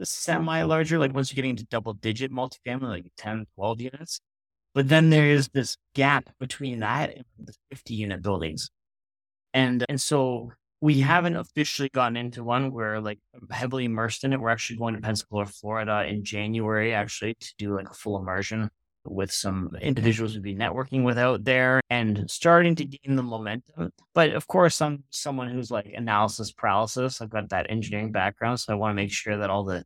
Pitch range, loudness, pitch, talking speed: 105-135 Hz, -26 LUFS, 115 Hz, 190 wpm